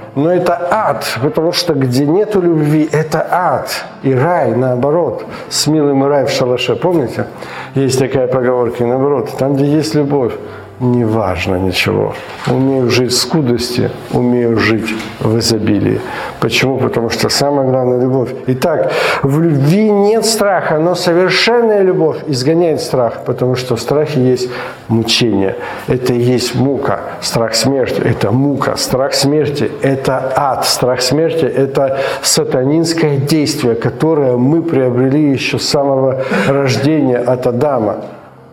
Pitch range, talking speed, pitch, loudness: 125-150 Hz, 135 wpm, 130 Hz, -13 LUFS